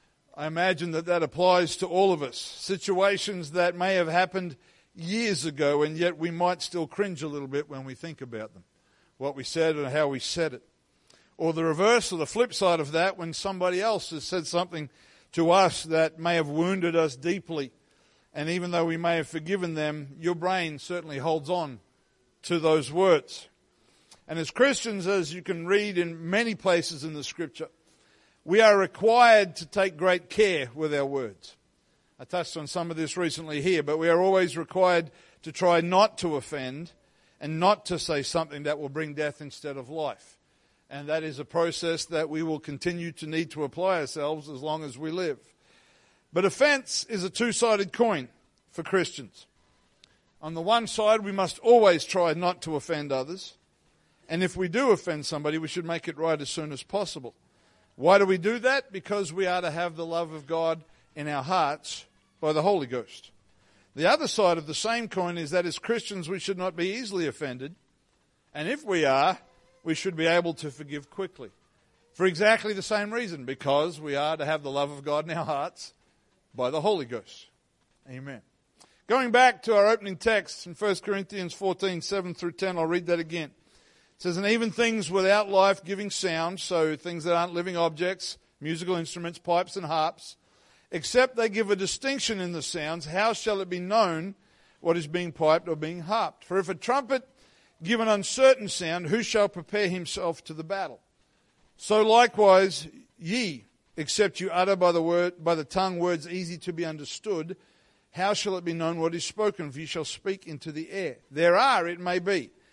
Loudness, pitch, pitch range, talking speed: -26 LUFS, 175 Hz, 155-195 Hz, 195 wpm